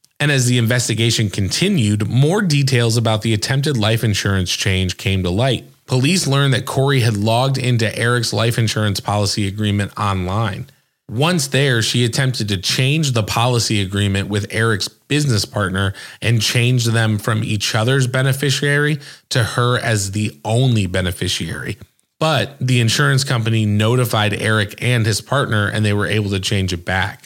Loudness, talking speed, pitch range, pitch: -17 LUFS, 160 wpm, 105-130 Hz, 115 Hz